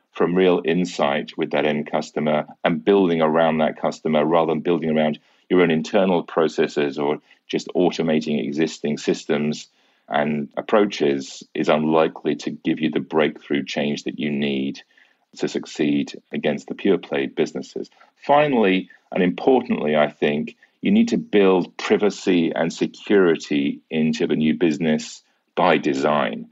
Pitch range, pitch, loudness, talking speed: 75-90 Hz, 80 Hz, -21 LUFS, 145 wpm